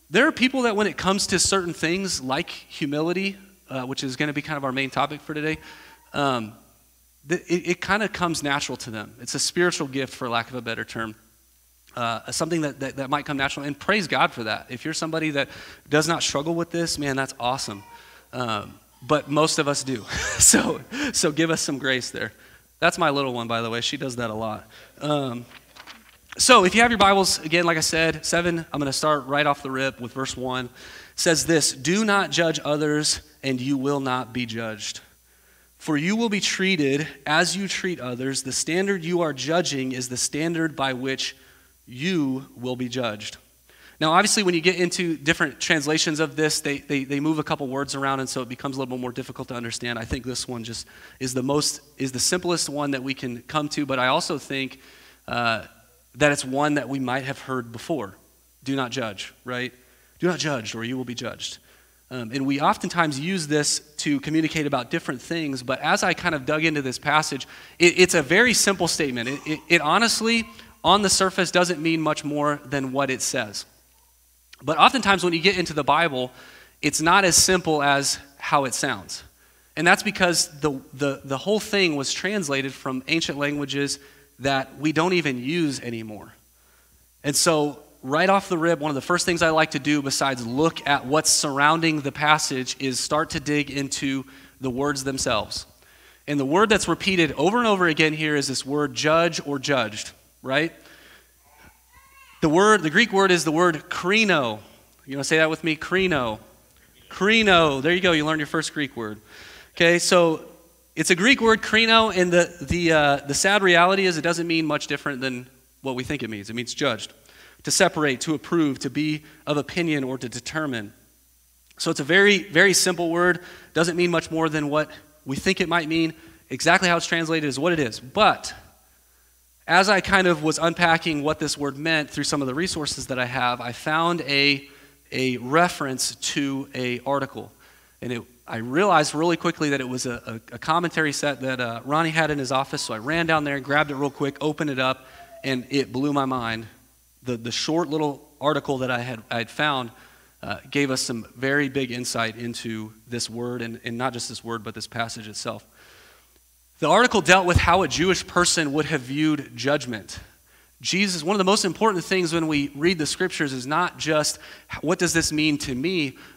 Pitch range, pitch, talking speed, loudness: 130-170 Hz, 145 Hz, 205 wpm, -22 LUFS